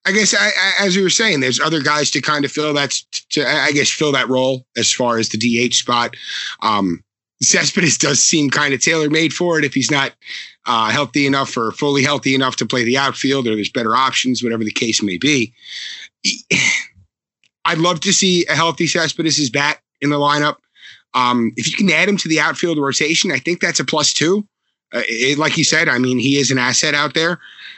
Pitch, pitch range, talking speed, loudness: 145 Hz, 125-160 Hz, 220 wpm, -15 LUFS